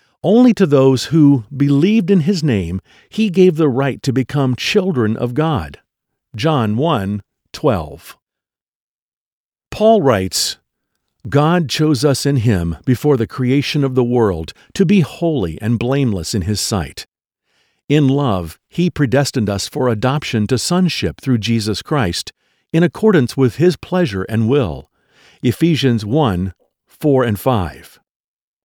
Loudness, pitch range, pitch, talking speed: -16 LUFS, 110-155 Hz, 135 Hz, 130 wpm